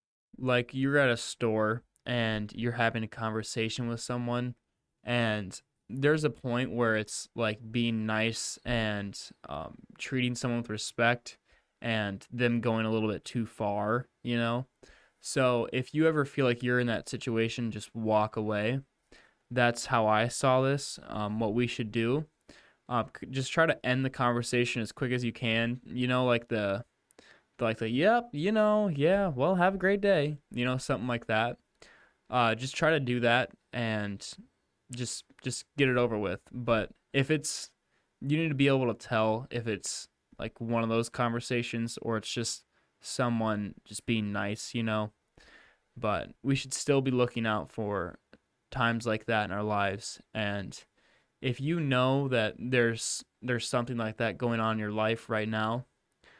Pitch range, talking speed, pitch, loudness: 110-125 Hz, 170 wpm, 120 Hz, -30 LUFS